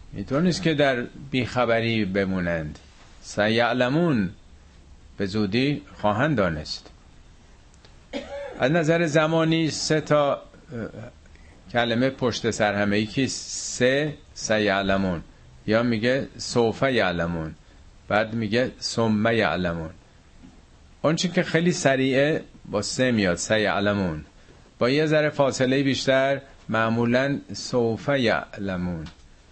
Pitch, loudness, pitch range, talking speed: 115 Hz, -23 LUFS, 95-135 Hz, 100 wpm